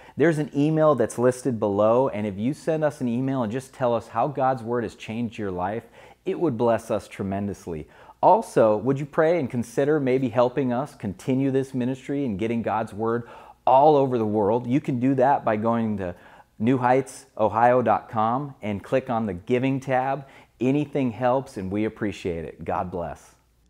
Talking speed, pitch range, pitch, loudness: 180 wpm, 110-135 Hz, 125 Hz, -24 LUFS